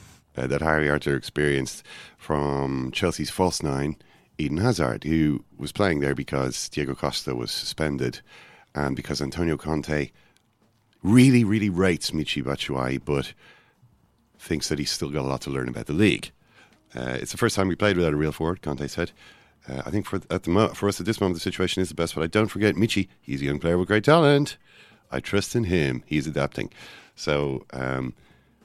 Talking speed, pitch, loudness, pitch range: 195 wpm, 75 Hz, -25 LUFS, 70-95 Hz